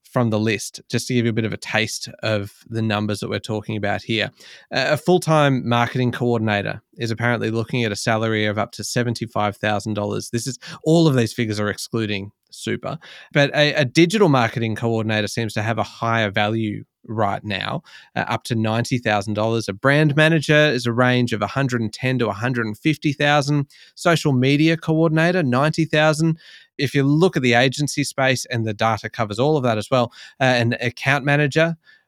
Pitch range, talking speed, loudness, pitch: 110-145 Hz, 195 wpm, -20 LUFS, 120 Hz